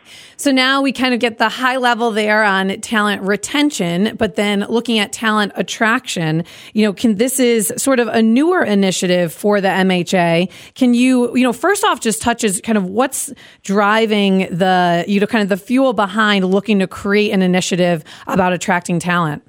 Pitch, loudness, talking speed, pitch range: 210 Hz, -15 LUFS, 185 wpm, 190-240 Hz